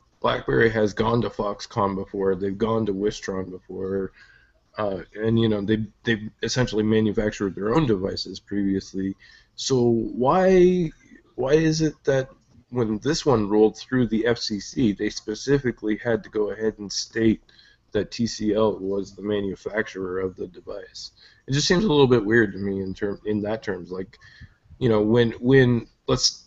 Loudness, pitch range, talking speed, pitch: -23 LUFS, 100-120 Hz, 165 wpm, 110 Hz